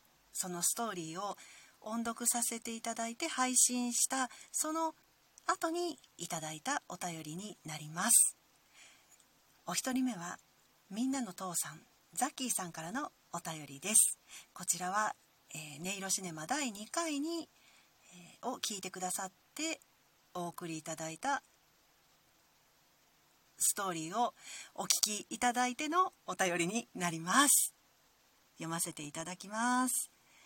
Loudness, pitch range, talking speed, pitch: -34 LUFS, 175-255 Hz, 260 characters per minute, 215 Hz